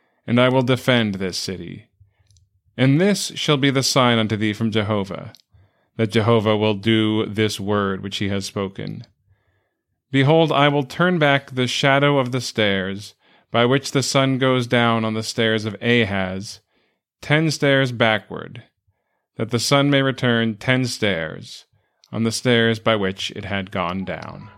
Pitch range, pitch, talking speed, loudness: 100-130 Hz, 115 Hz, 160 wpm, -19 LUFS